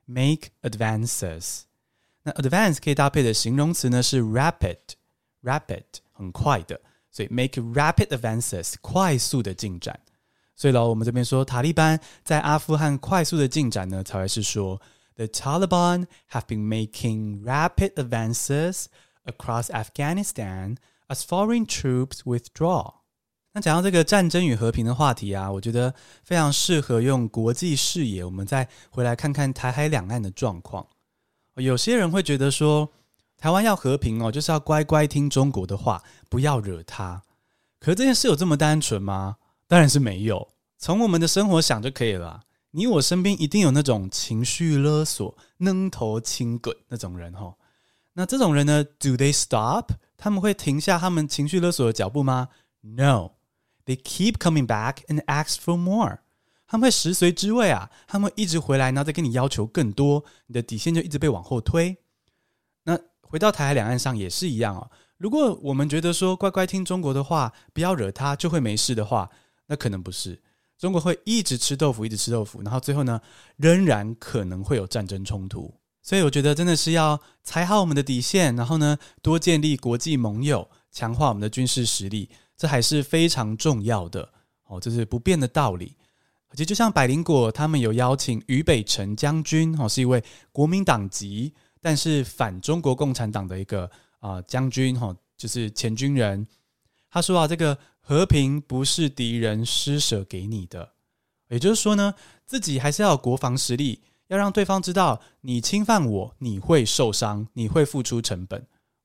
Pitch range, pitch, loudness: 115-160 Hz, 135 Hz, -23 LUFS